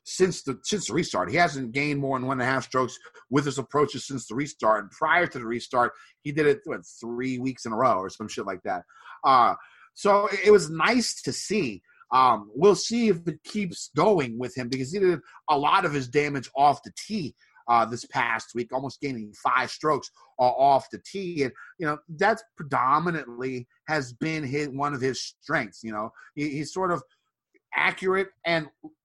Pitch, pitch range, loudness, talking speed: 140 Hz, 125-175 Hz, -26 LUFS, 200 wpm